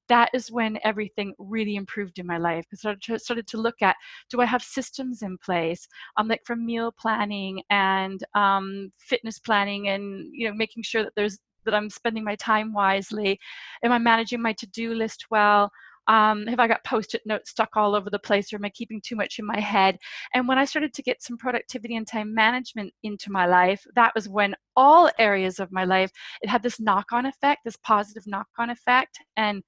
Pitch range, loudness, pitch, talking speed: 200-235 Hz, -24 LUFS, 220 Hz, 210 wpm